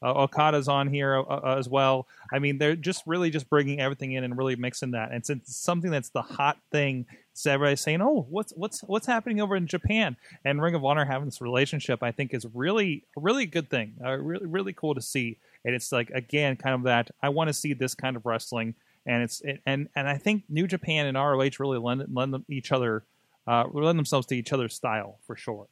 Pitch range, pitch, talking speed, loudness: 125-155 Hz, 140 Hz, 235 wpm, -27 LUFS